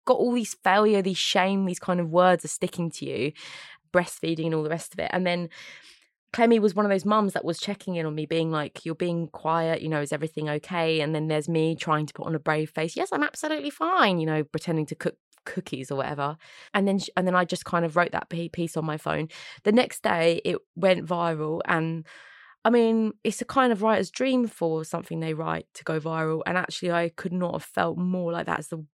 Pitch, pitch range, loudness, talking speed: 170 Hz, 160-195 Hz, -26 LUFS, 240 wpm